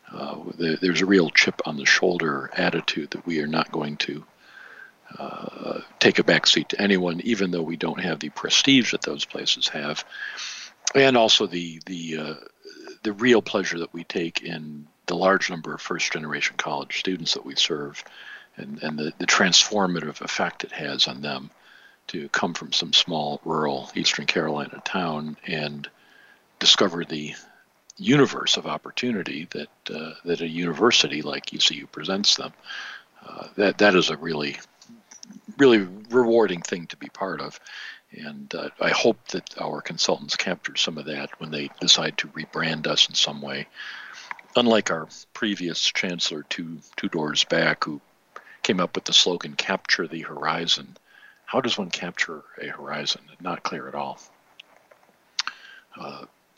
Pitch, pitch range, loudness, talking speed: 85 Hz, 75-100 Hz, -23 LUFS, 160 wpm